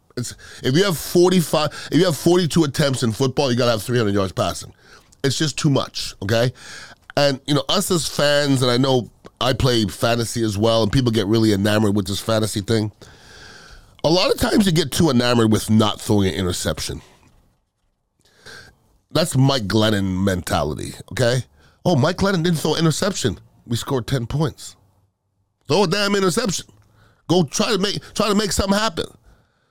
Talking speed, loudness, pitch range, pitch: 180 wpm, -19 LUFS, 105-155 Hz, 125 Hz